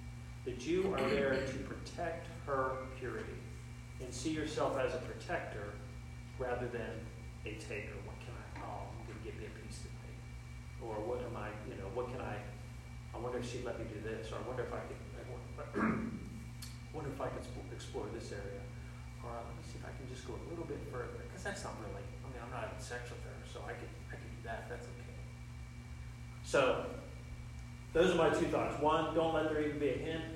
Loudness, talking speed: -40 LUFS, 215 wpm